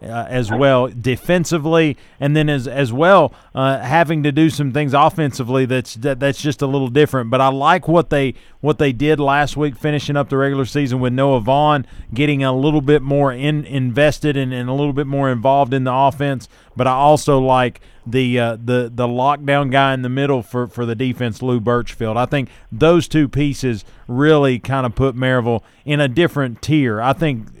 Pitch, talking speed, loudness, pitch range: 135 Hz, 200 wpm, -17 LUFS, 125-145 Hz